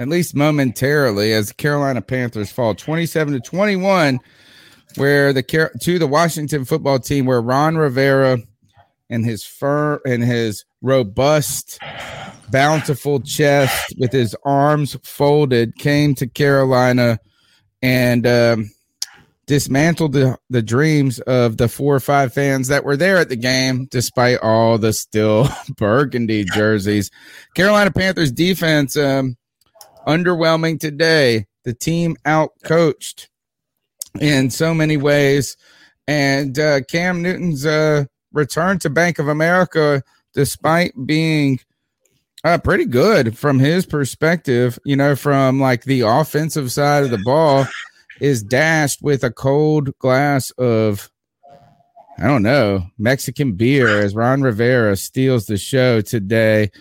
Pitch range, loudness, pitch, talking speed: 120-150 Hz, -16 LUFS, 135 Hz, 130 wpm